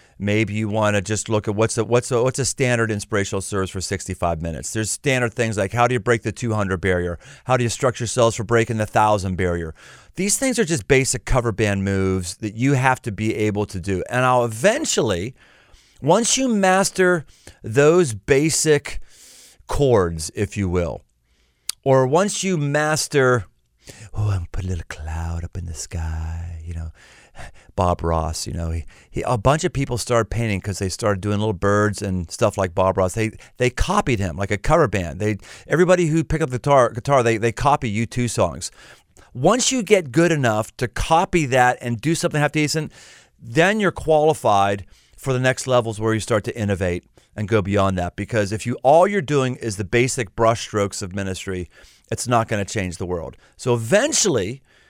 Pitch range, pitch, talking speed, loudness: 95-130 Hz, 110 Hz, 195 wpm, -20 LUFS